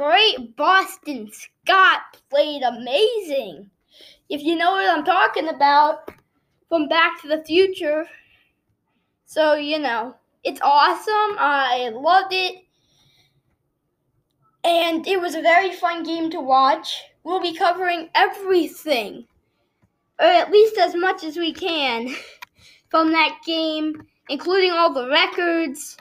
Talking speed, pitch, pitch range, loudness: 120 wpm, 330 Hz, 295-365 Hz, -19 LUFS